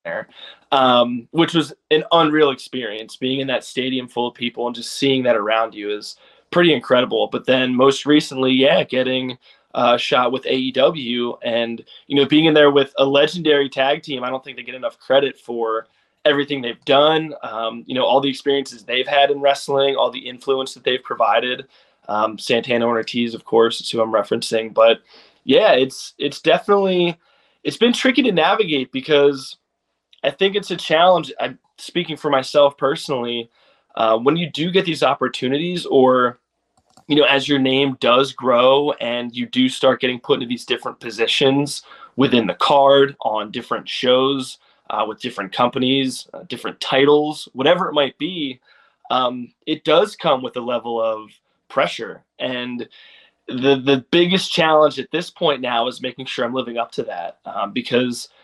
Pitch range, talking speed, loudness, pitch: 120-145 Hz, 175 wpm, -18 LUFS, 135 Hz